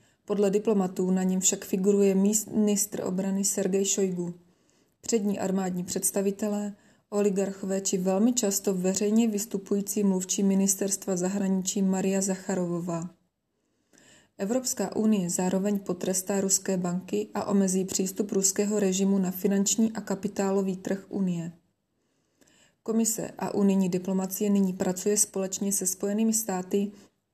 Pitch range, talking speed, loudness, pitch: 190-205 Hz, 110 wpm, -27 LUFS, 195 Hz